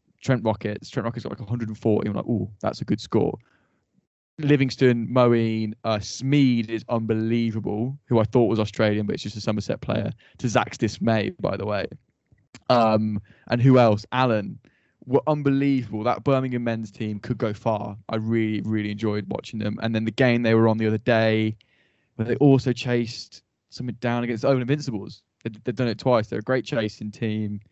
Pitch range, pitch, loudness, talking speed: 110-125 Hz, 115 Hz, -24 LUFS, 185 wpm